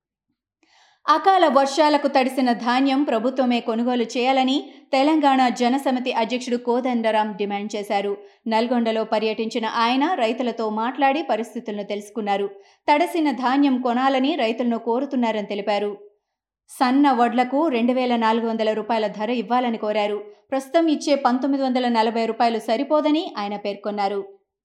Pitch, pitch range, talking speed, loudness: 240 Hz, 220-270 Hz, 110 wpm, -21 LUFS